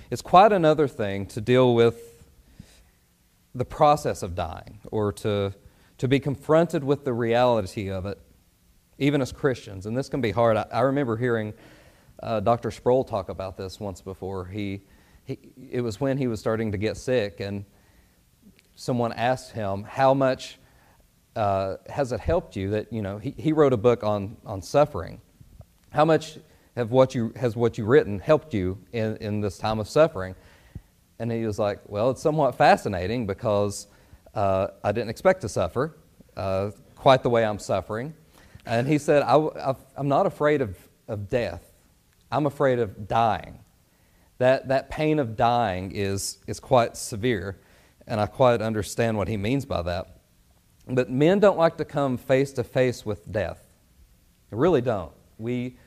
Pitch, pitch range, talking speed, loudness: 110 Hz, 100-130 Hz, 170 wpm, -24 LUFS